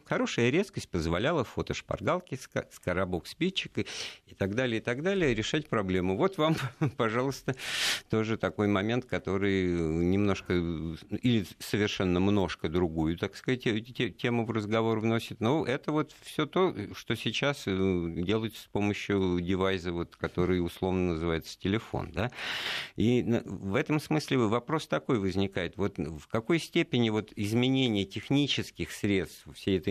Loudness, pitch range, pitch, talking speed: -30 LUFS, 95-125 Hz, 110 Hz, 130 wpm